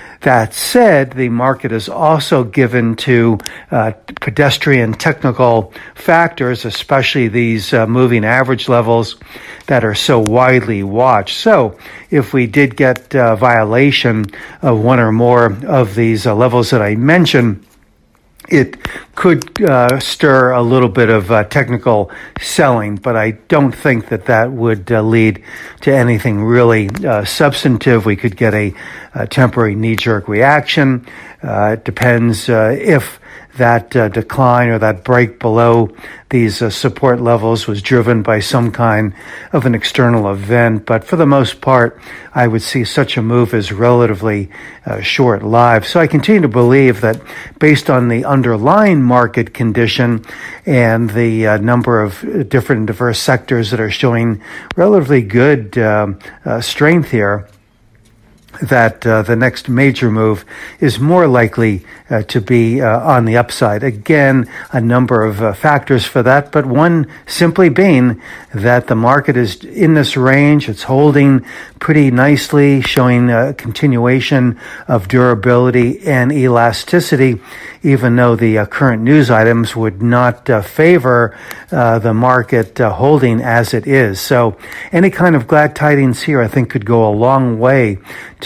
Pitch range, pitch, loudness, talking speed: 115-135 Hz, 120 Hz, -12 LUFS, 155 wpm